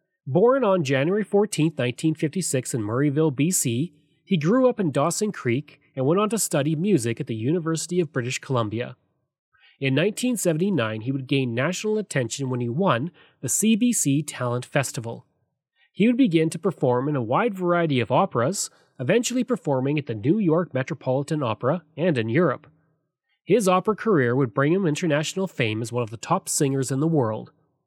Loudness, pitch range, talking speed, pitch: -23 LUFS, 135-180 Hz, 170 wpm, 155 Hz